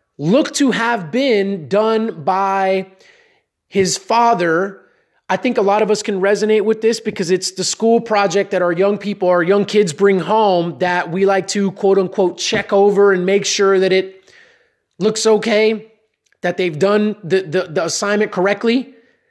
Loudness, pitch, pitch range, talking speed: -16 LUFS, 200 Hz, 190-220 Hz, 170 wpm